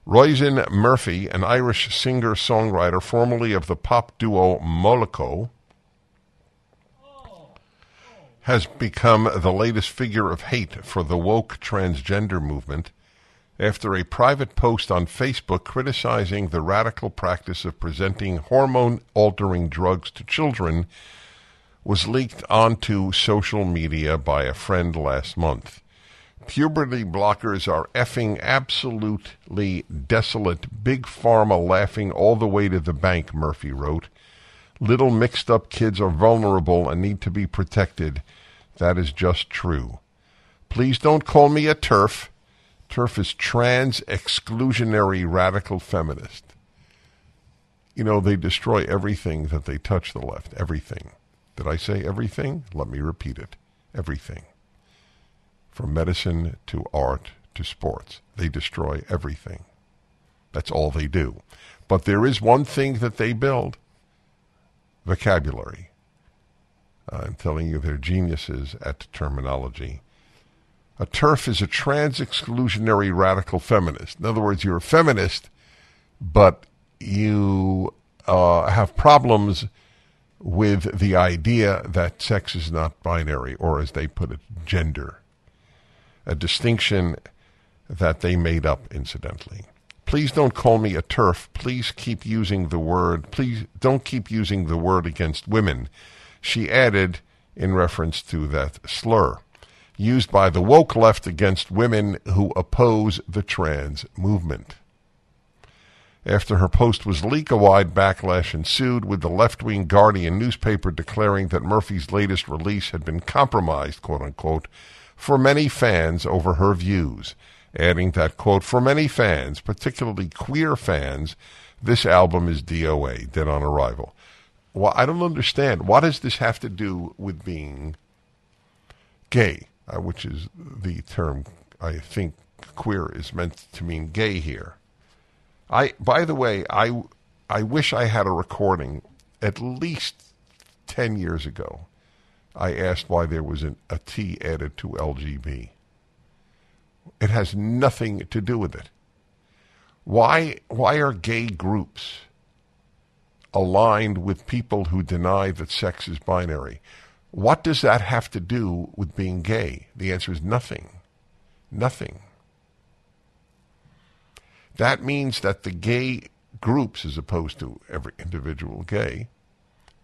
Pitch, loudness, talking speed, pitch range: 95 Hz, -22 LUFS, 130 wpm, 85-115 Hz